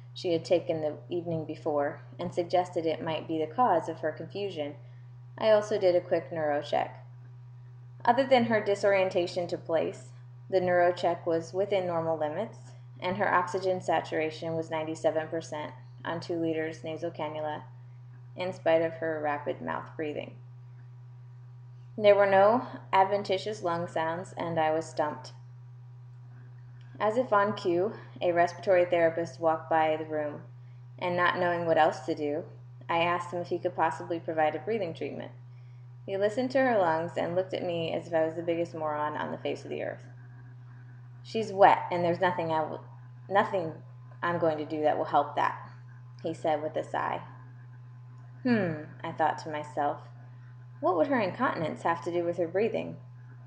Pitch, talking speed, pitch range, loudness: 160 Hz, 170 wpm, 125-175 Hz, -29 LUFS